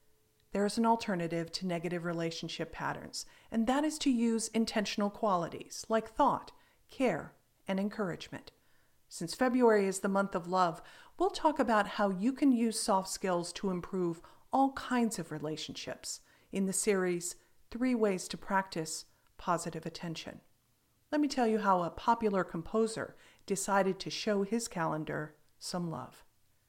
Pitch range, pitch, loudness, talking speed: 170-230 Hz, 195 Hz, -33 LUFS, 150 wpm